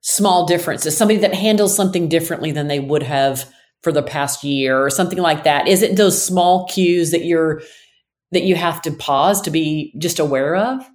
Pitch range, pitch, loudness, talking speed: 150-190 Hz, 170 Hz, -16 LUFS, 195 wpm